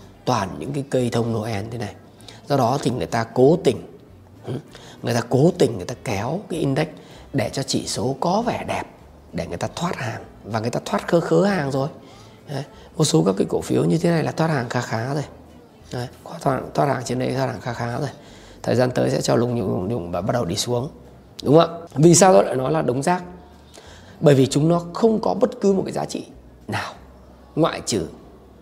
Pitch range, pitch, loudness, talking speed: 105-155 Hz, 125 Hz, -21 LUFS, 230 wpm